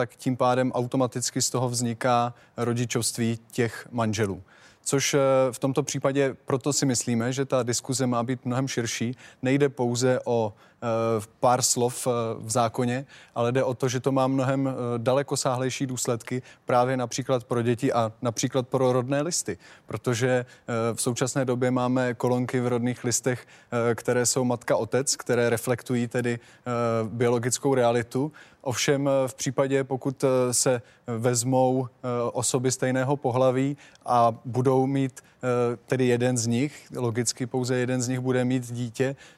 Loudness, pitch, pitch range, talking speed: -26 LUFS, 125 Hz, 120-130 Hz, 140 wpm